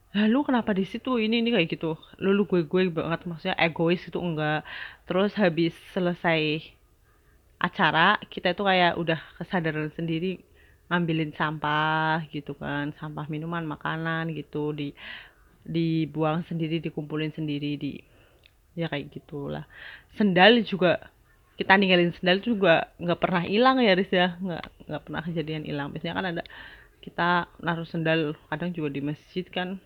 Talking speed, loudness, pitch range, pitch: 145 wpm, -26 LUFS, 155-185 Hz, 165 Hz